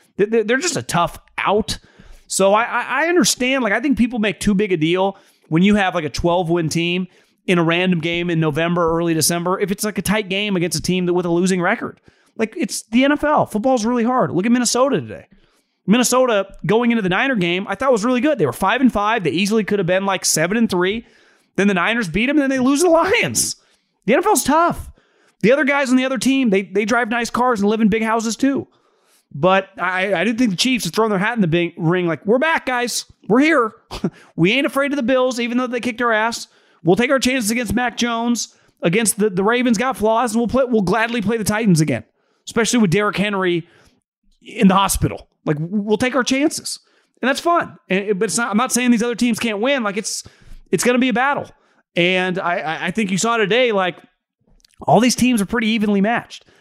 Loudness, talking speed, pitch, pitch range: -18 LUFS, 230 wpm, 220 Hz, 190-250 Hz